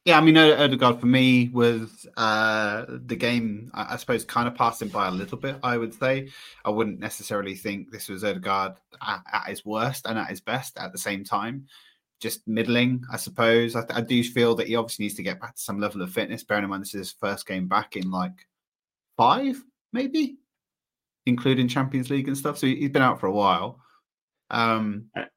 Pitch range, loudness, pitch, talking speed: 105-130 Hz, -24 LUFS, 115 Hz, 210 wpm